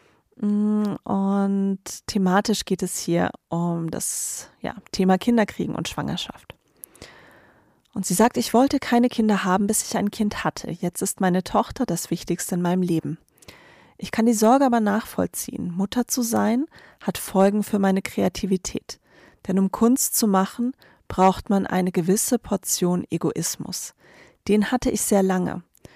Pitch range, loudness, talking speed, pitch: 185-225 Hz, -23 LUFS, 150 wpm, 195 Hz